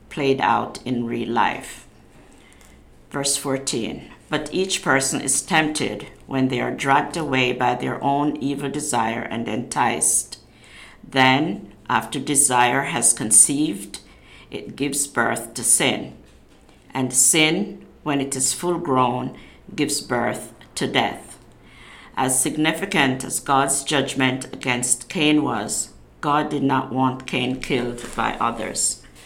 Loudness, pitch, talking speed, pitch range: -20 LUFS, 135 Hz, 125 wpm, 125-145 Hz